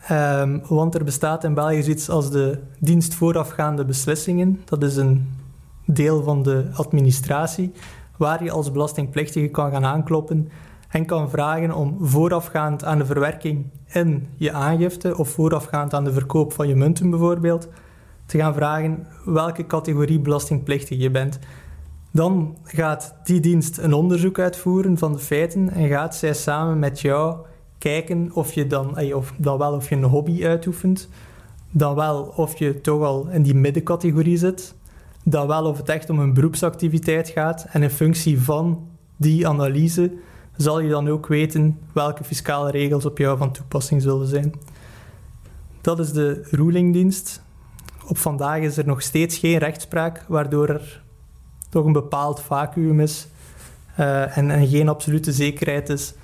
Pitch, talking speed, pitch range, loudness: 150 Hz, 155 wpm, 145-165 Hz, -21 LUFS